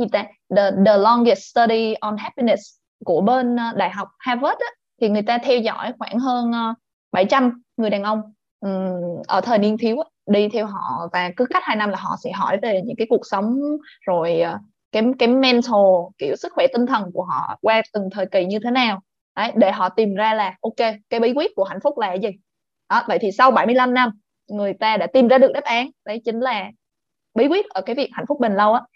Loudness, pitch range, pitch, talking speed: -19 LUFS, 205-250 Hz, 225 Hz, 220 wpm